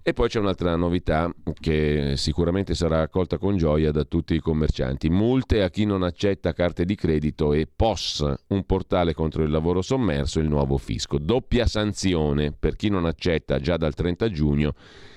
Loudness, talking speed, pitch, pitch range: -24 LUFS, 175 wpm, 85 Hz, 75-95 Hz